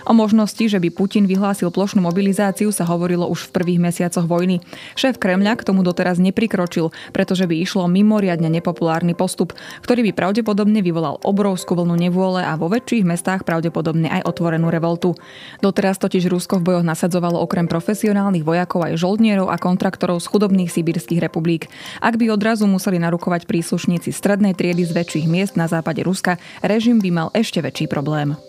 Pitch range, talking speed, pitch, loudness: 170-200 Hz, 165 wpm, 180 Hz, -18 LUFS